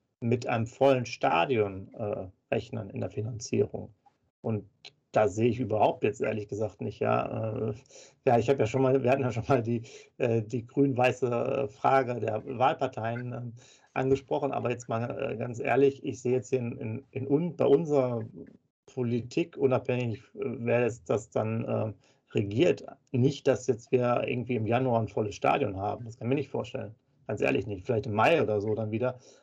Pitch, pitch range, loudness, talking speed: 125 Hz, 110-135 Hz, -29 LUFS, 185 wpm